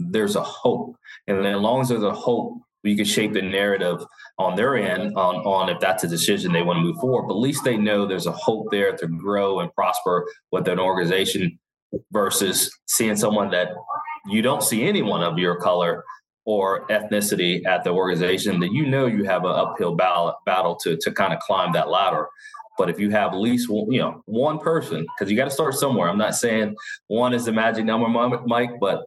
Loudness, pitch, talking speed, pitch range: -22 LUFS, 105 Hz, 215 wpm, 100-130 Hz